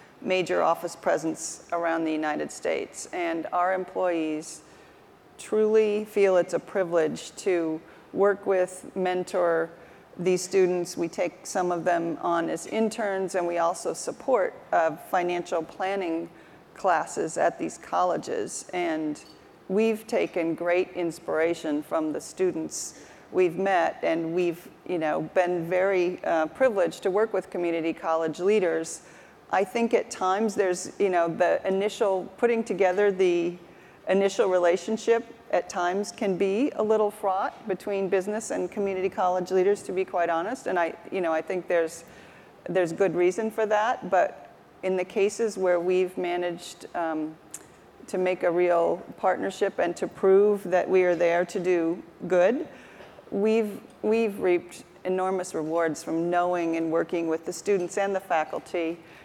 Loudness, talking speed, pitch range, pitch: -26 LUFS, 145 wpm, 170-200 Hz, 185 Hz